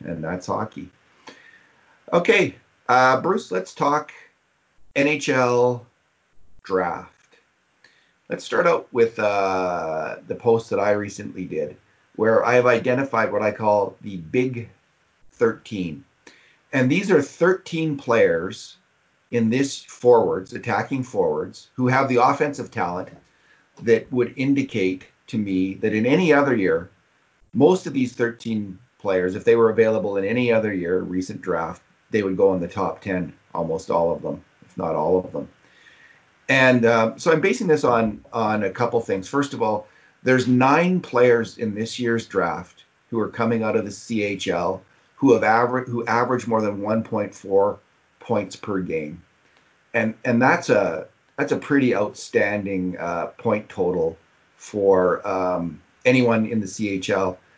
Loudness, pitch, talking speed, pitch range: -21 LUFS, 115 Hz, 150 wpm, 100-130 Hz